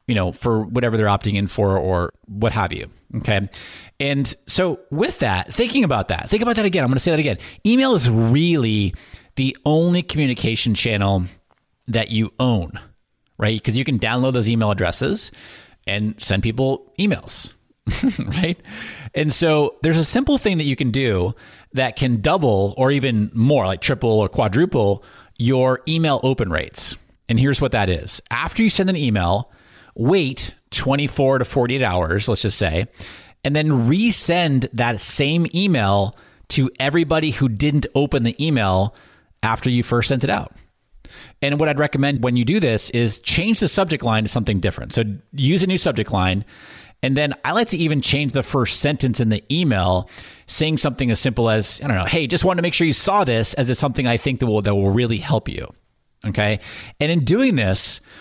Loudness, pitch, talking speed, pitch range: -19 LUFS, 125 Hz, 190 wpm, 105-150 Hz